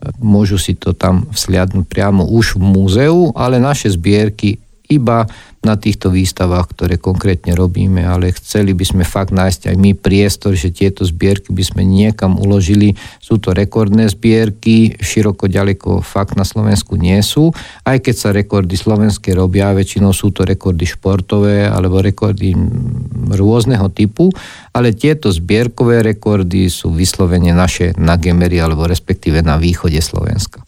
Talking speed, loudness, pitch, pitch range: 150 wpm, -13 LUFS, 100 Hz, 95-110 Hz